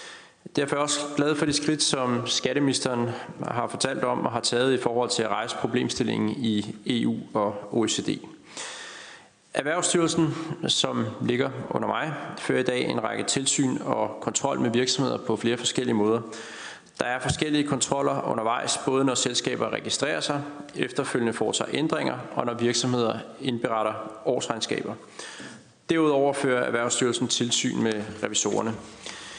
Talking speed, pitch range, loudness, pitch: 140 wpm, 120-145 Hz, -26 LUFS, 125 Hz